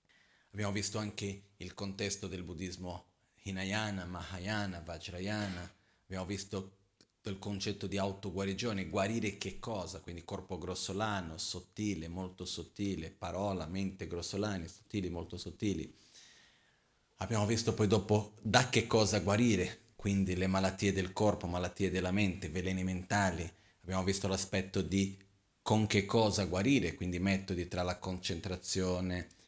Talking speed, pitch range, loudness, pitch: 125 wpm, 90-105 Hz, -35 LUFS, 95 Hz